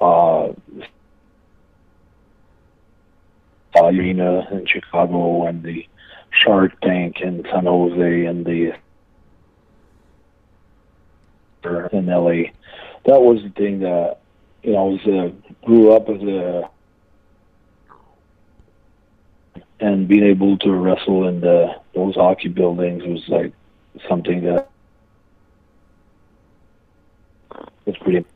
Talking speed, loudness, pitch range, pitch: 95 wpm, -17 LUFS, 85-95 Hz, 90 Hz